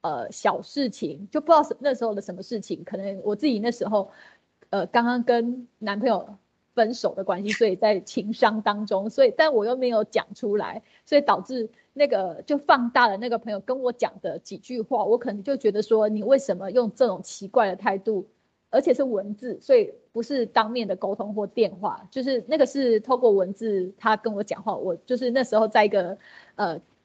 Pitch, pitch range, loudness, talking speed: 225 Hz, 205-250 Hz, -24 LUFS, 300 characters per minute